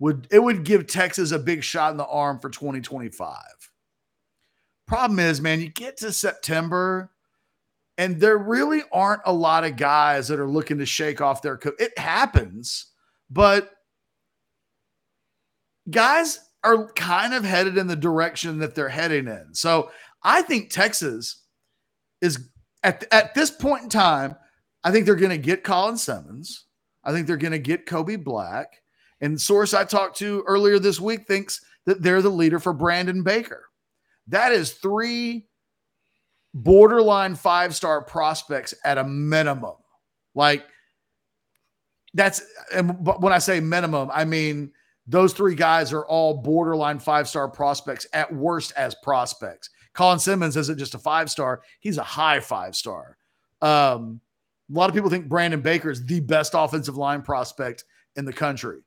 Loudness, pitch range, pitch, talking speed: -21 LUFS, 150-195 Hz, 170 Hz, 155 wpm